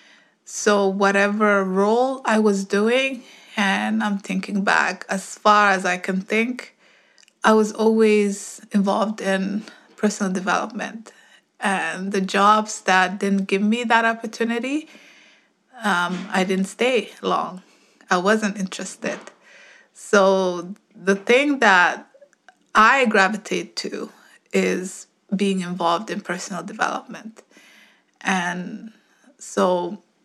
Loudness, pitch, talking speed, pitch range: -20 LUFS, 200 Hz, 110 wpm, 190-220 Hz